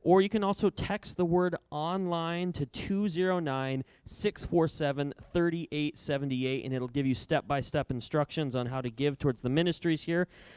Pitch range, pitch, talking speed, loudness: 135-180 Hz, 150 Hz, 160 wpm, -31 LUFS